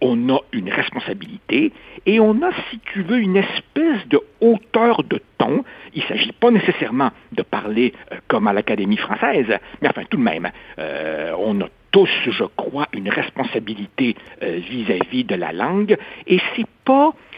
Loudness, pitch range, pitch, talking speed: -19 LUFS, 180-245 Hz, 220 Hz, 165 wpm